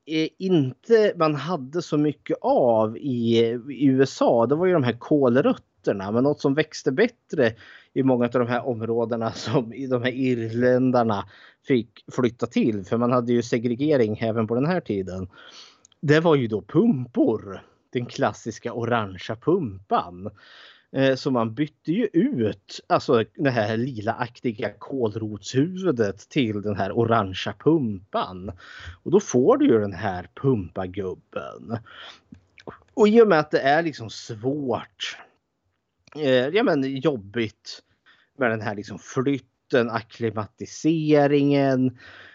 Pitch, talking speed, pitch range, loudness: 120 Hz, 135 wpm, 110-140 Hz, -23 LUFS